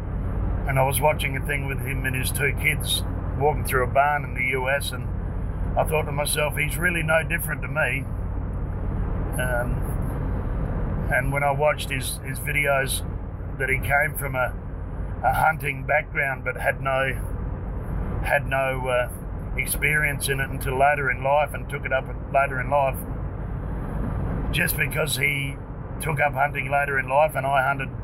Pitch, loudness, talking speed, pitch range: 130 Hz, -24 LUFS, 165 wpm, 100-140 Hz